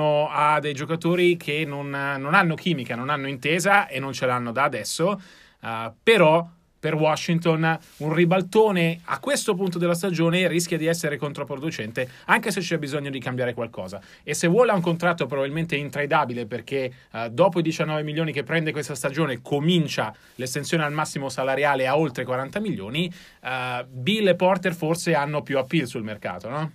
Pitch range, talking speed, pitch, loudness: 140-170 Hz, 170 wpm, 155 Hz, -23 LUFS